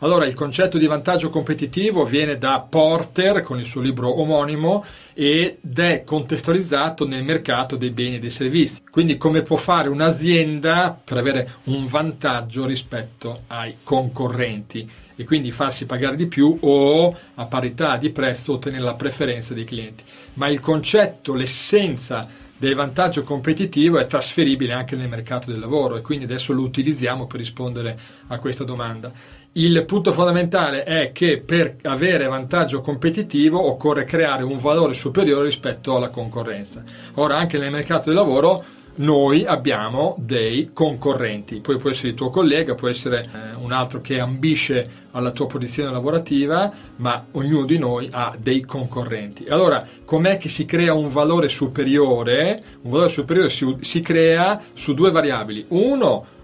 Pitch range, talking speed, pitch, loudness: 125-160 Hz, 155 wpm, 140 Hz, -20 LUFS